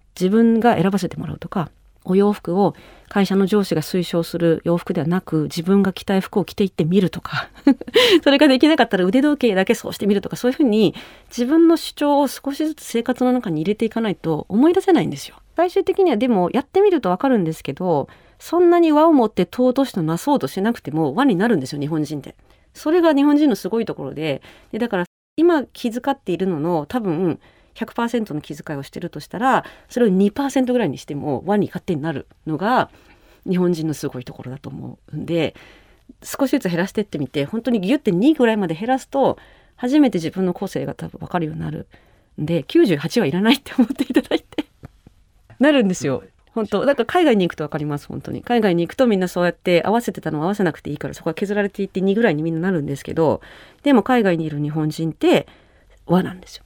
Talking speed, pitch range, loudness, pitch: 410 characters per minute, 165-250 Hz, -19 LUFS, 195 Hz